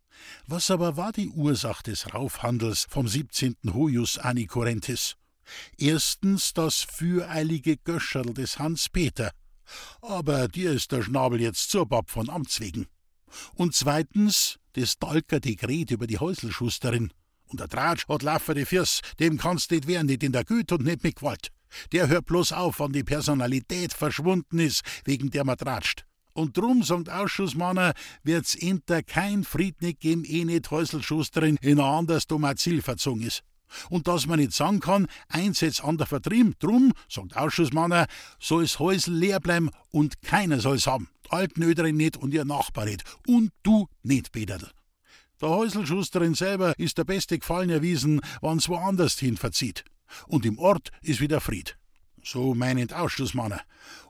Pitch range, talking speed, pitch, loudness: 130-175 Hz, 155 wpm, 155 Hz, -26 LUFS